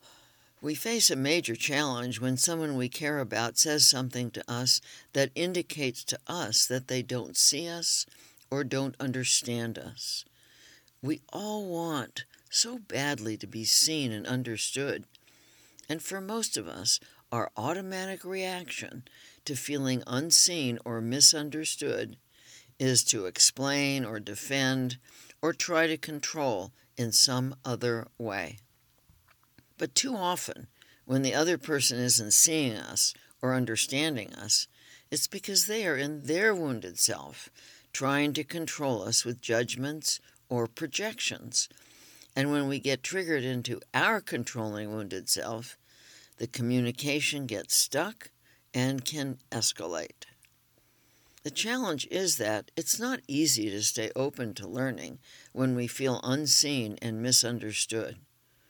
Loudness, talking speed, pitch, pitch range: -28 LUFS, 130 wpm, 130 Hz, 120-150 Hz